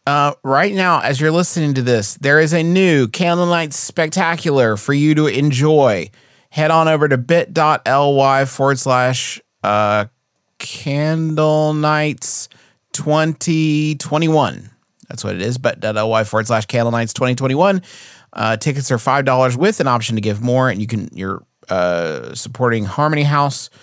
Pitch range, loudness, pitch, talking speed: 125-155 Hz, -16 LUFS, 140 Hz, 150 wpm